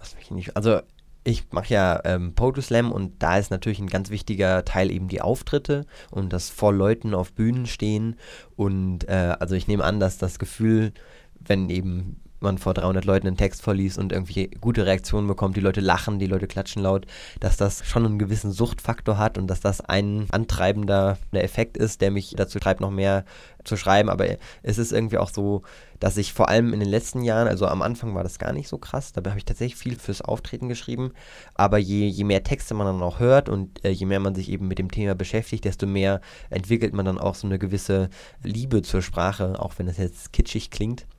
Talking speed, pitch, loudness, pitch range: 215 wpm, 100 Hz, -24 LUFS, 95-110 Hz